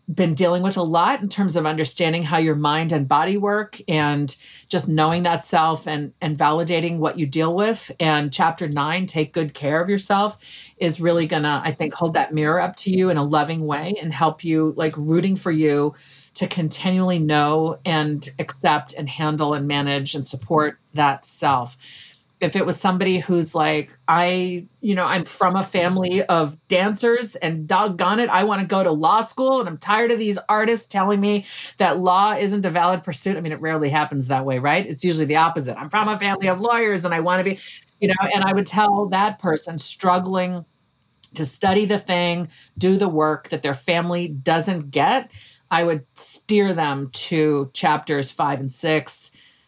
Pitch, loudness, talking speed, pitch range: 170 Hz, -20 LUFS, 195 wpm, 150-190 Hz